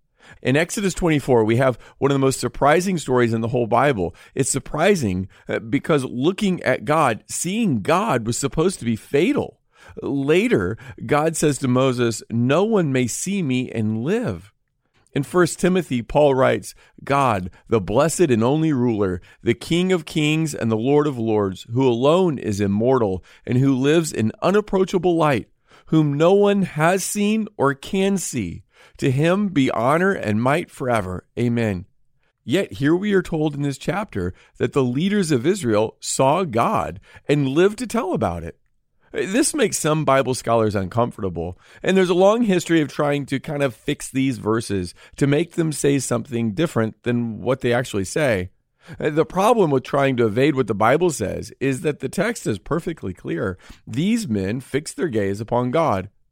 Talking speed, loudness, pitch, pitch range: 170 wpm, -20 LUFS, 135 Hz, 115-160 Hz